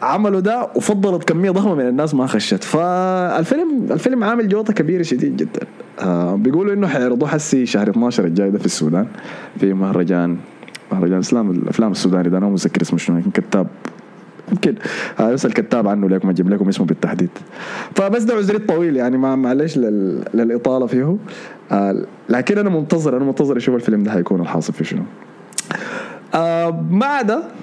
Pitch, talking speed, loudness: 155 Hz, 160 wpm, -17 LUFS